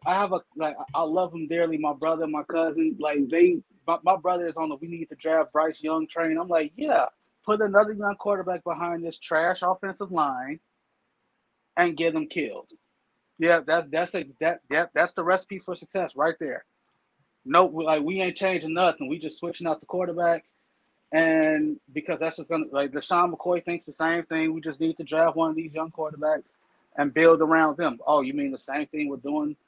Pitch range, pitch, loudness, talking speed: 160-180 Hz, 165 Hz, -25 LUFS, 210 wpm